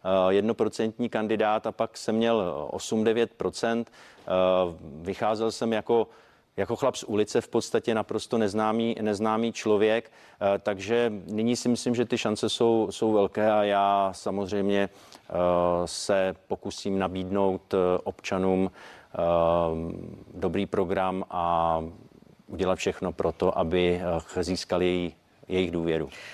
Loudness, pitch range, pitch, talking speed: -27 LUFS, 90-110 Hz, 100 Hz, 110 wpm